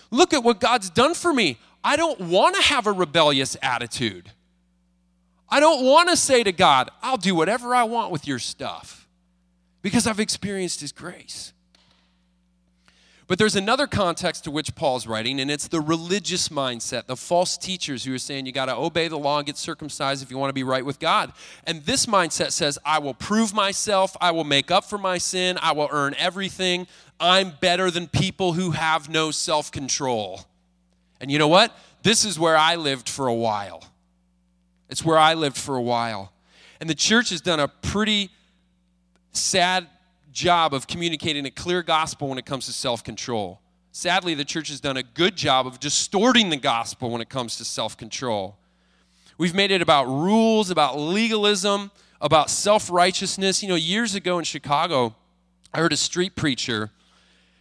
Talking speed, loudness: 180 wpm, -22 LUFS